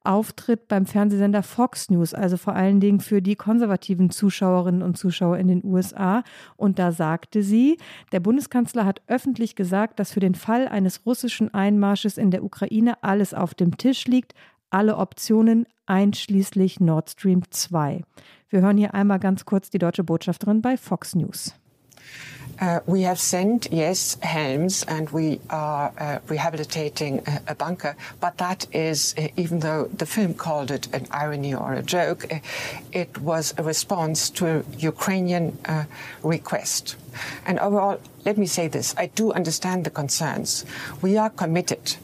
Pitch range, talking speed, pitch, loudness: 160-205 Hz, 160 wpm, 185 Hz, -23 LUFS